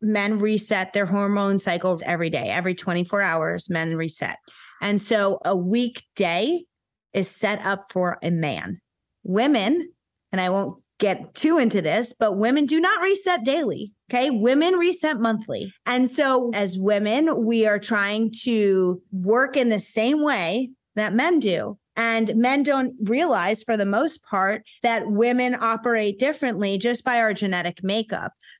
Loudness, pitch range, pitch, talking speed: -22 LUFS, 195-250 Hz, 220 Hz, 155 wpm